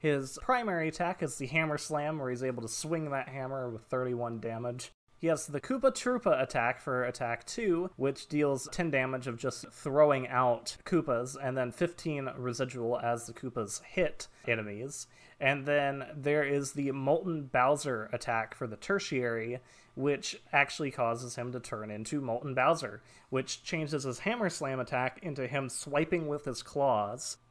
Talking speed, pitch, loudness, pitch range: 165 wpm, 135 Hz, -33 LUFS, 120-150 Hz